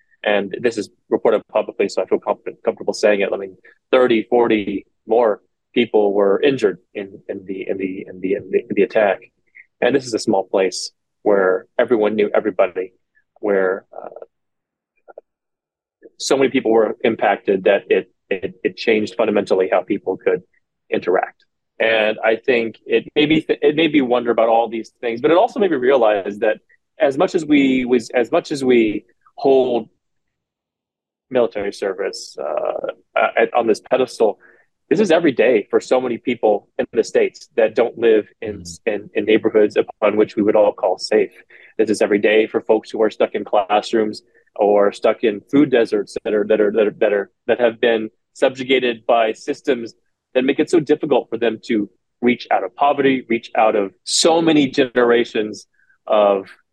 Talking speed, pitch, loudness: 180 wpm, 130 Hz, -18 LUFS